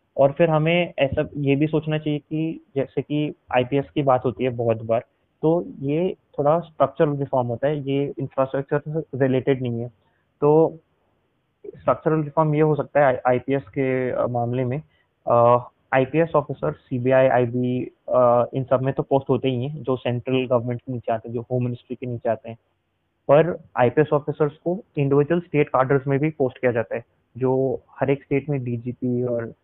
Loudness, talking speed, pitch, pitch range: -22 LUFS, 180 wpm, 135 Hz, 125-150 Hz